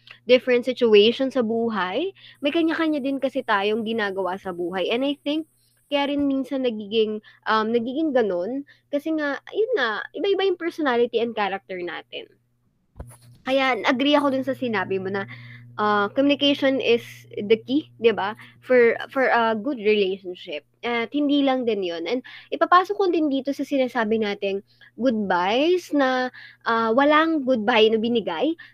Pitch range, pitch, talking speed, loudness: 210-285 Hz, 245 Hz, 150 wpm, -22 LUFS